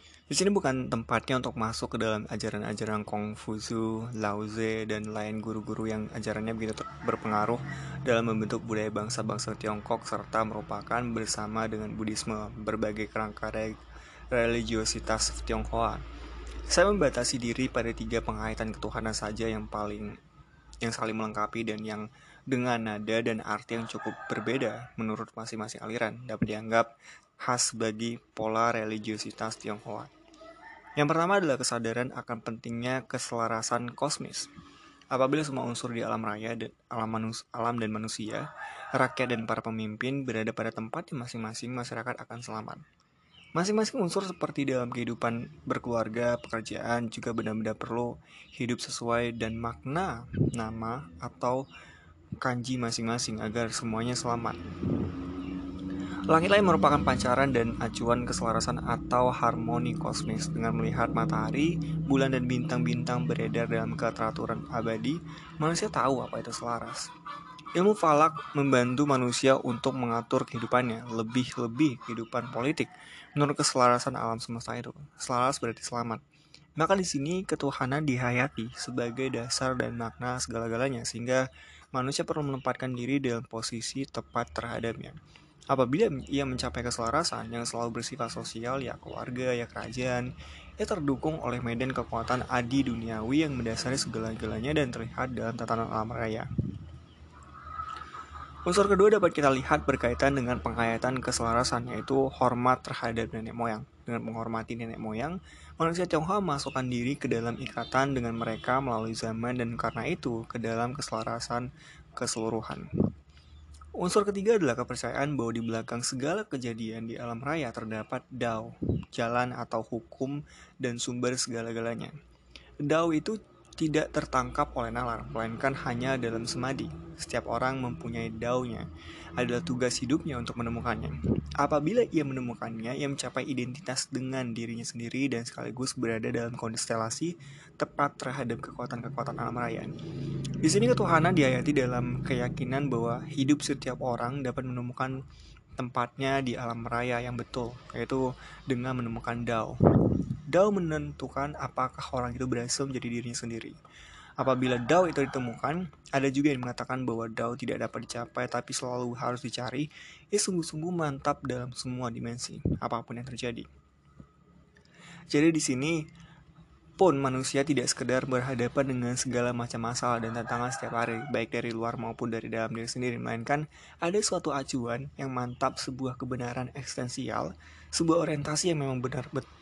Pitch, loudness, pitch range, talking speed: 120 Hz, -31 LUFS, 115-135 Hz, 130 wpm